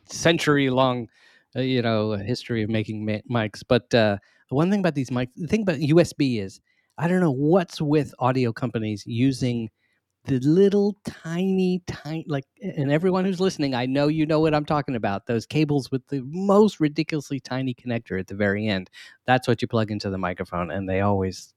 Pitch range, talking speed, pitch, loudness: 110-155 Hz, 190 wpm, 130 Hz, -24 LUFS